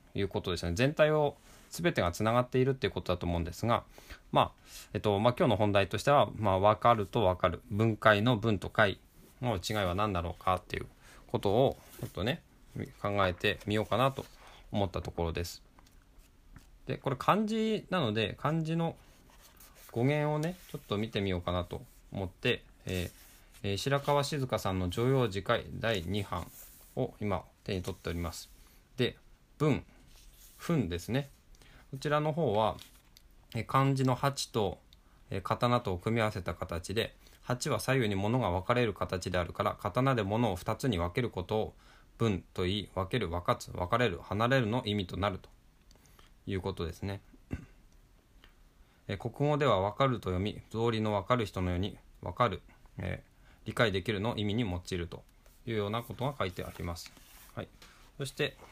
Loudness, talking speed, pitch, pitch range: -32 LUFS, 315 characters per minute, 105 Hz, 95-125 Hz